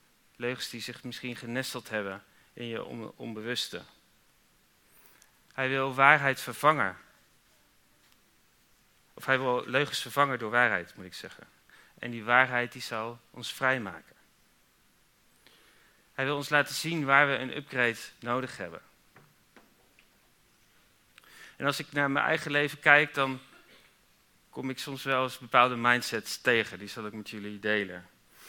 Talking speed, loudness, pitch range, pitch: 135 wpm, -28 LUFS, 120-140 Hz, 125 Hz